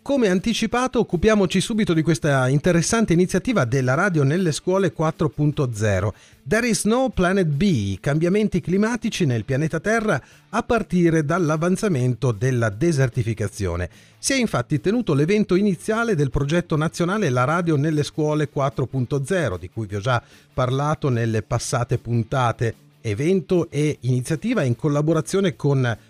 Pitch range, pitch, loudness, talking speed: 125-185 Hz, 155 Hz, -21 LUFS, 130 wpm